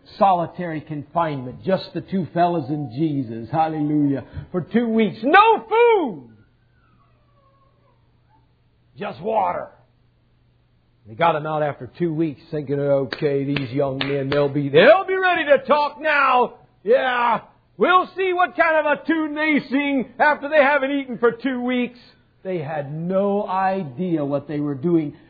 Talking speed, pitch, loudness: 145 wpm, 175 Hz, -20 LUFS